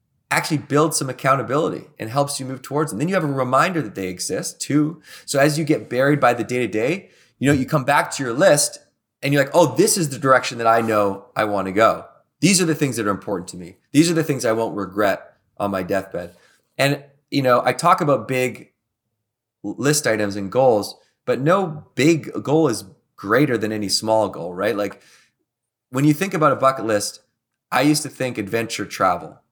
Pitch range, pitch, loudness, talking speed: 110-150 Hz, 130 Hz, -20 LUFS, 220 wpm